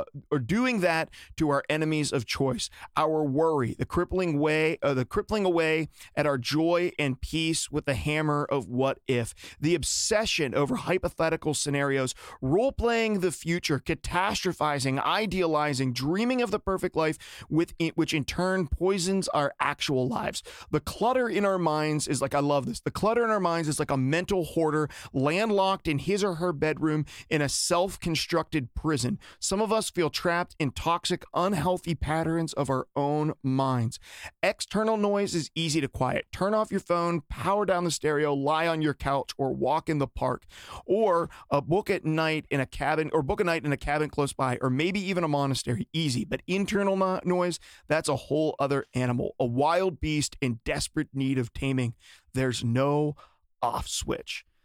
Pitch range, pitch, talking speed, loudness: 140-180 Hz, 155 Hz, 180 wpm, -27 LUFS